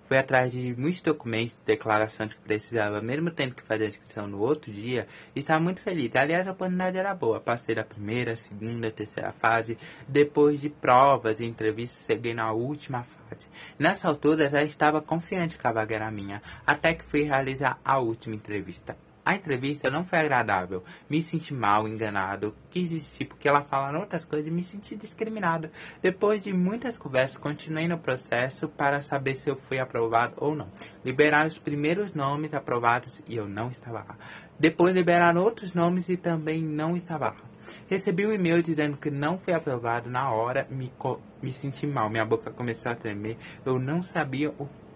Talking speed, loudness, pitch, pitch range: 185 wpm, -27 LUFS, 140 Hz, 115-160 Hz